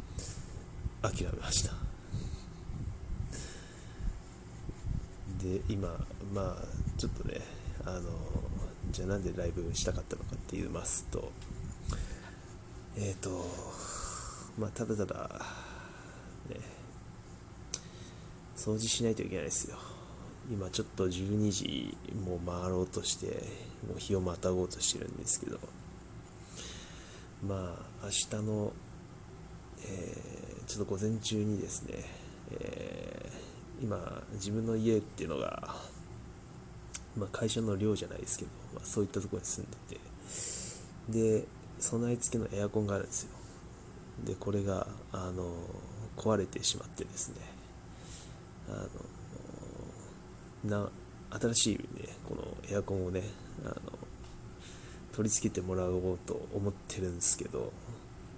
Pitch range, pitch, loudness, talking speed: 90-110 Hz, 100 Hz, -33 LUFS, 230 characters per minute